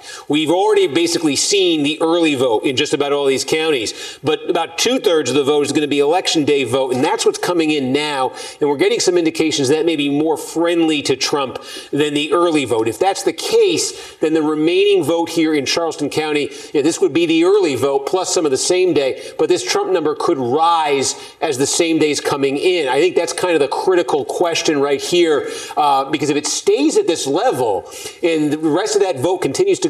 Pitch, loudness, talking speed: 370 Hz, -16 LUFS, 225 wpm